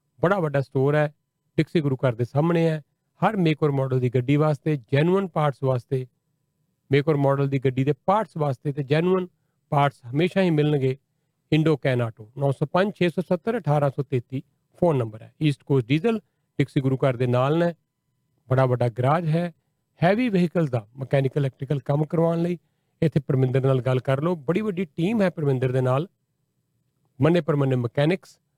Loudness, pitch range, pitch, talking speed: -23 LUFS, 135-165 Hz, 145 Hz, 155 wpm